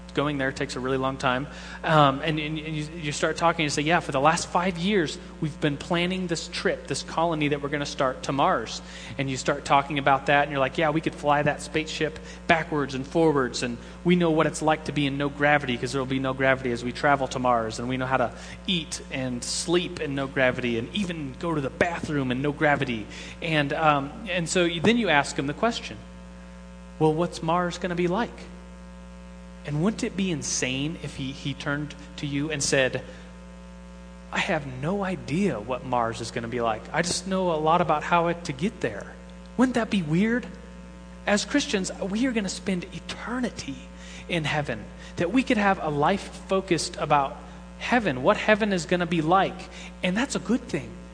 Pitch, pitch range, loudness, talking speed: 150 Hz, 130-175 Hz, -25 LUFS, 215 wpm